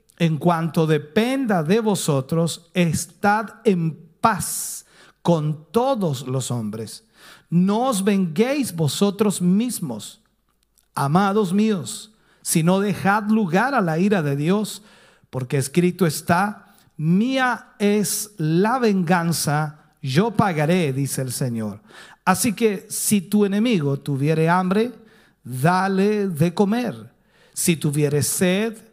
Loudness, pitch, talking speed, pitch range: -21 LUFS, 185 Hz, 110 wpm, 160-215 Hz